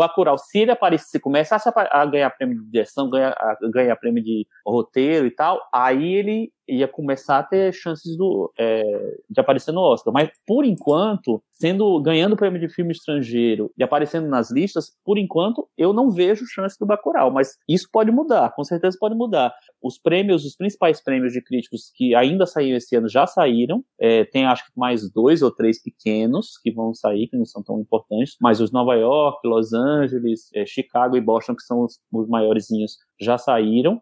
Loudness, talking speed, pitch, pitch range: -20 LUFS, 185 wpm, 140 Hz, 120-185 Hz